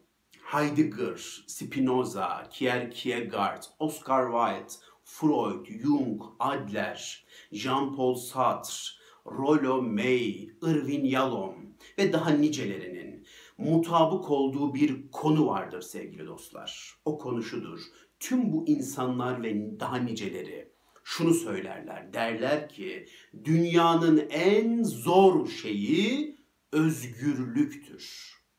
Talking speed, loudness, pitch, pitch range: 85 wpm, -28 LUFS, 155 Hz, 130-185 Hz